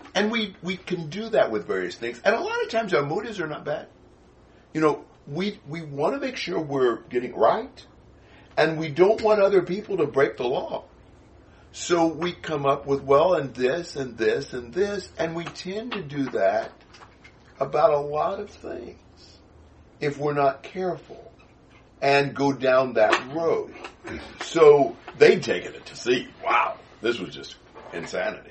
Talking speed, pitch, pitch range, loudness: 175 wpm, 160 Hz, 140-200 Hz, -24 LUFS